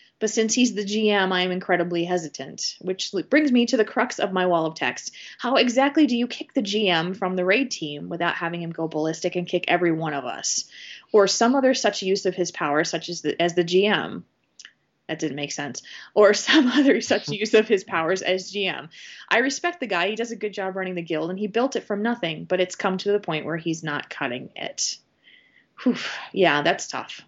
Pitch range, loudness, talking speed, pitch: 170-225 Hz, -23 LUFS, 225 wpm, 190 Hz